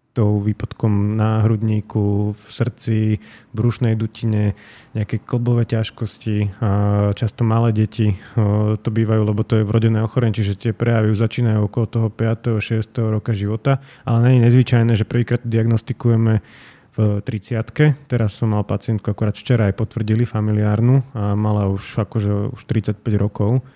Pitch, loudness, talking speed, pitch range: 110 Hz, -19 LUFS, 145 wpm, 105-115 Hz